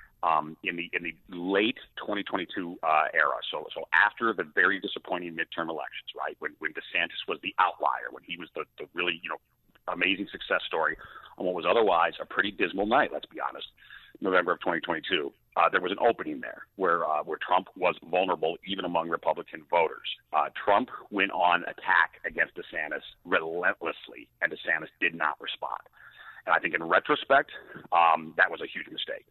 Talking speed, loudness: 180 wpm, -28 LUFS